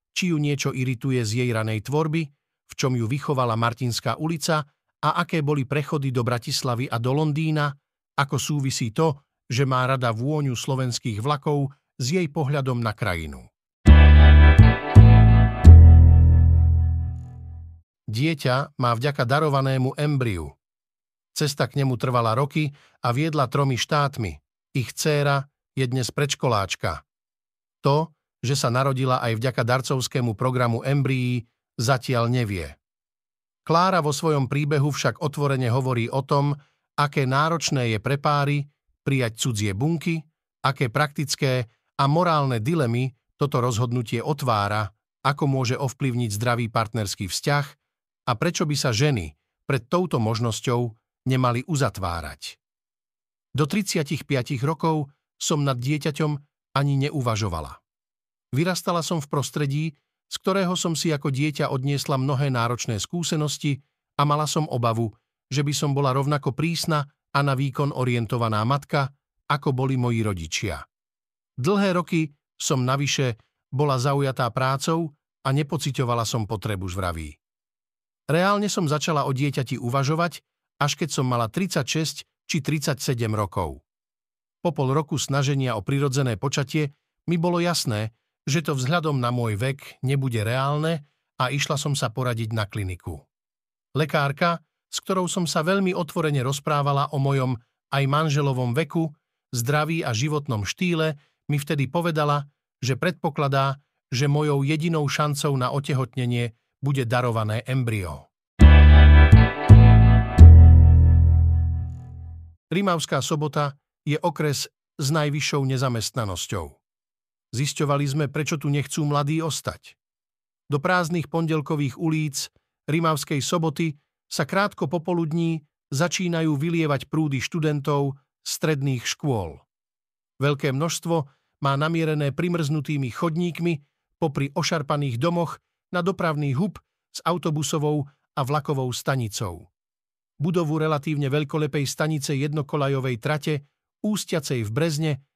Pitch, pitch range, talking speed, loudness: 140 Hz, 125-155 Hz, 120 wpm, -22 LUFS